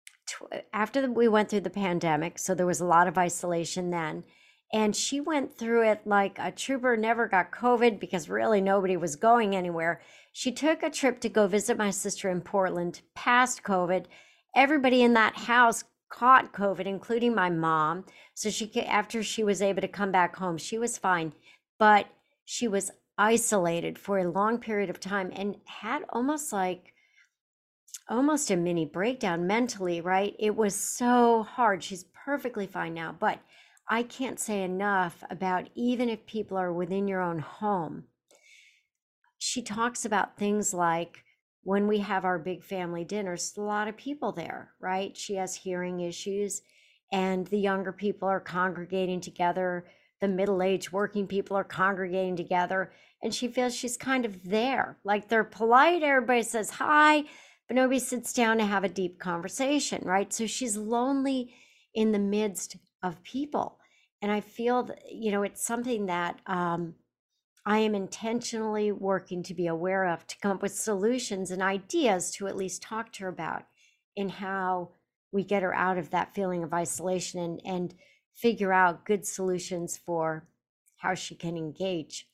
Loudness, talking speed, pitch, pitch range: -28 LUFS, 170 wpm, 200 Hz, 180-230 Hz